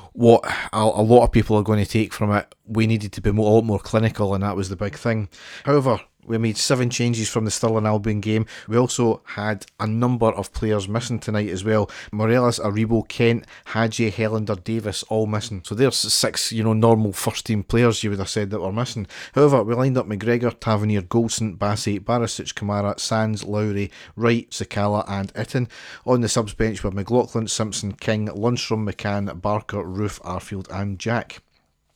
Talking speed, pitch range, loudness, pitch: 190 wpm, 105-115 Hz, -22 LUFS, 110 Hz